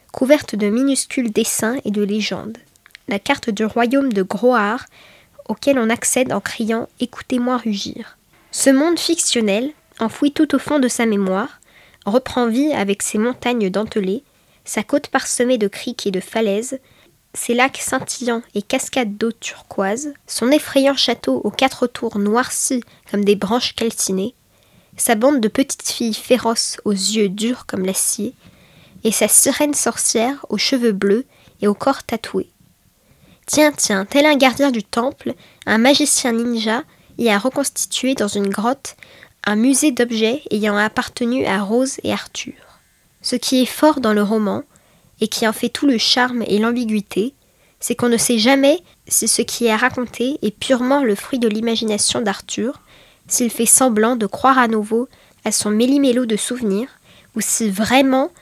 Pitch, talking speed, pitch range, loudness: 235 Hz, 160 wpm, 215-265 Hz, -17 LUFS